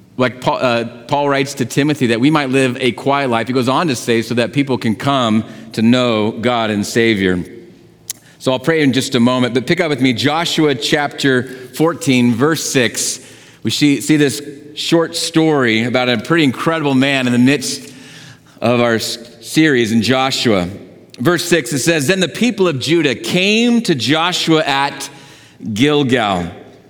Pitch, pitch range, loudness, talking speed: 135 Hz, 120-150 Hz, -15 LUFS, 175 wpm